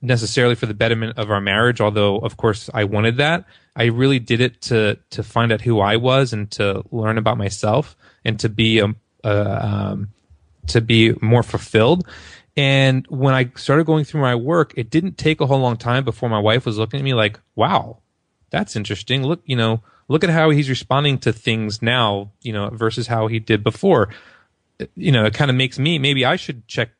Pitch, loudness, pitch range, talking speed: 115 Hz, -18 LUFS, 110-130 Hz, 210 wpm